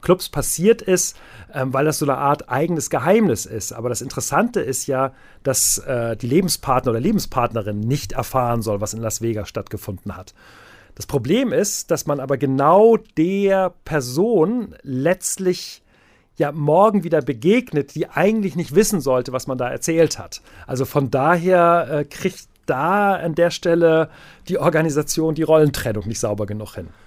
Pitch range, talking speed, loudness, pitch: 125-175 Hz, 155 wpm, -19 LUFS, 145 Hz